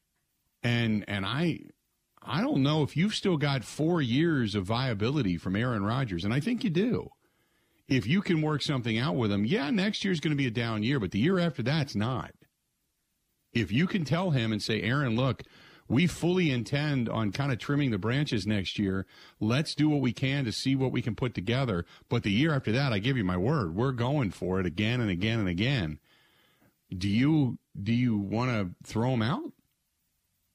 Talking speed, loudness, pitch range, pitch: 205 wpm, -29 LUFS, 105-145 Hz, 125 Hz